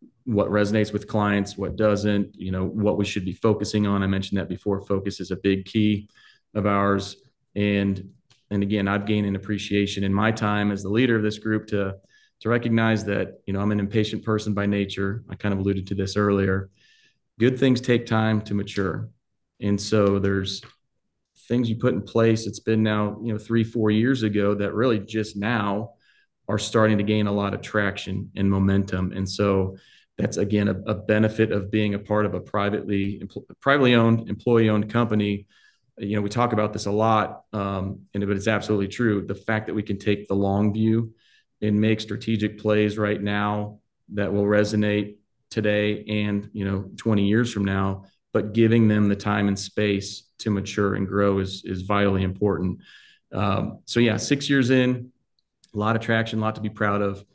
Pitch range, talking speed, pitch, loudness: 100-110 Hz, 200 wpm, 105 Hz, -24 LUFS